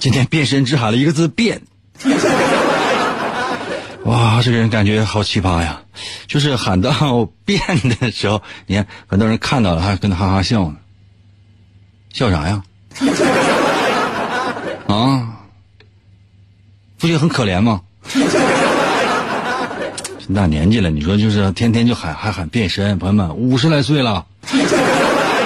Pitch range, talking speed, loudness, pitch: 100-120 Hz, 190 characters per minute, -16 LUFS, 105 Hz